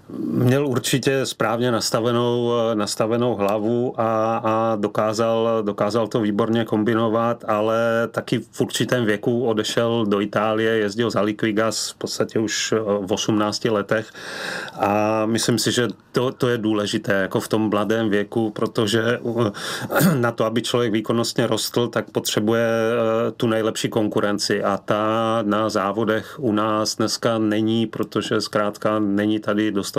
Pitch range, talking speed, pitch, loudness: 105-115 Hz, 135 wpm, 110 Hz, -21 LUFS